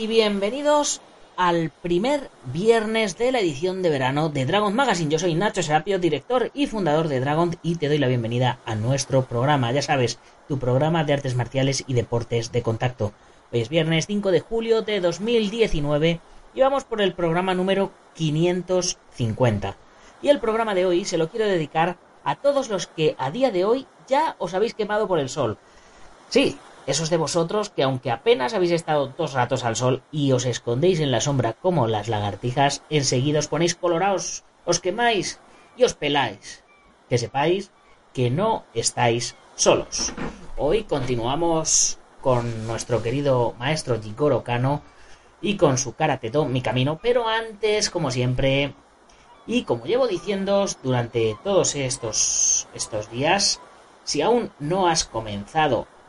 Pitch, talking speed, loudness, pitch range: 155 Hz, 160 wpm, -23 LUFS, 125-195 Hz